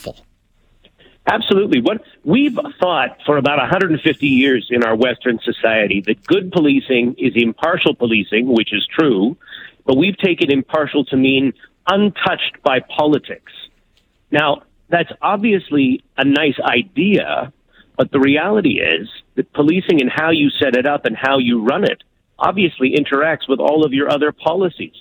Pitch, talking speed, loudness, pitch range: 145 Hz, 145 wpm, -16 LUFS, 130-175 Hz